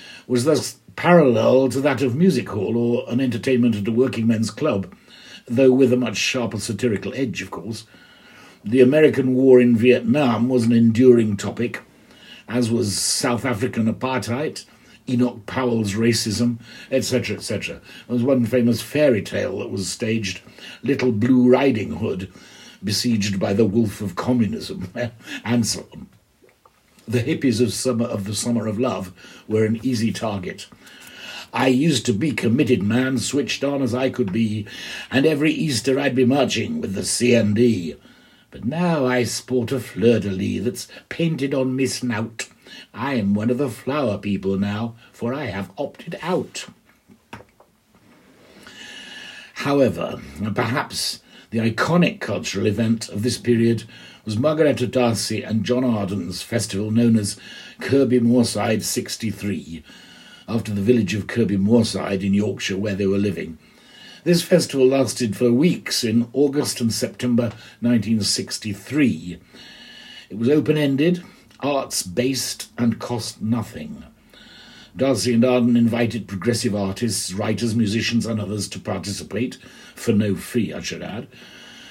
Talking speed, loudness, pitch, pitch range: 140 wpm, -21 LUFS, 120 Hz, 110-130 Hz